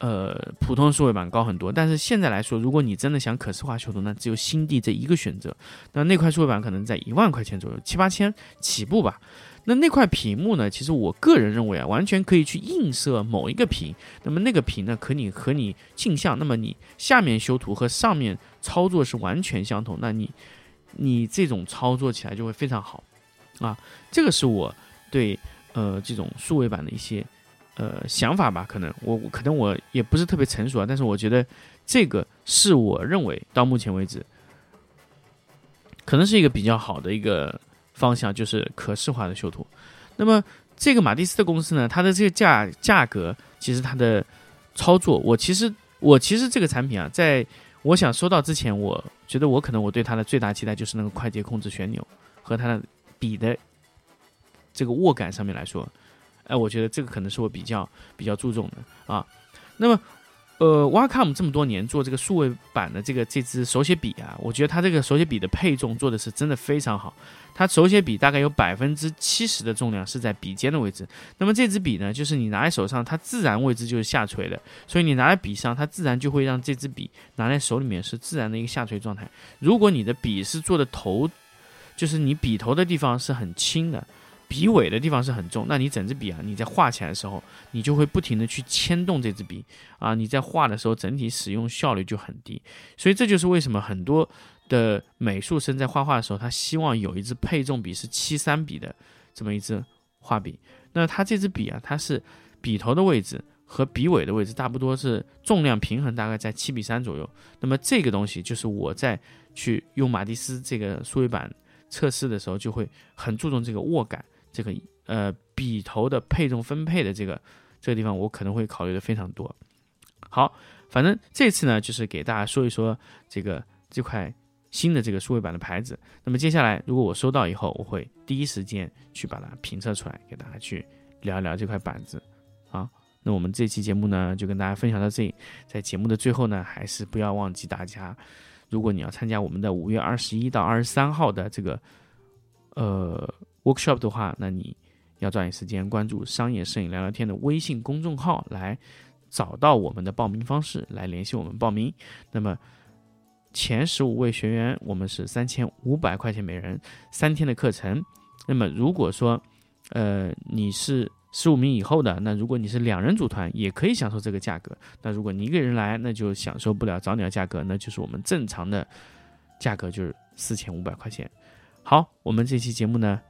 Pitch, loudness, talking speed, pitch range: 115 Hz, -24 LUFS, 310 characters per minute, 105-140 Hz